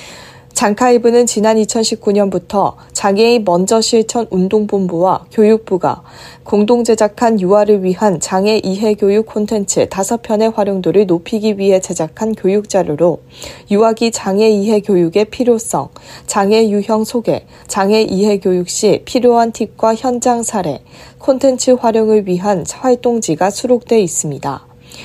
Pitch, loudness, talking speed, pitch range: 210 Hz, -13 LUFS, 285 characters per minute, 190-225 Hz